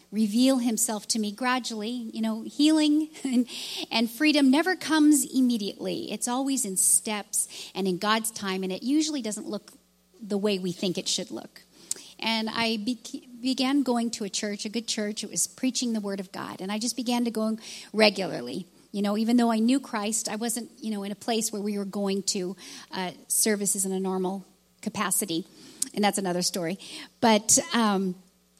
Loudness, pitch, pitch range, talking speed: -26 LUFS, 215 Hz, 195-245 Hz, 190 wpm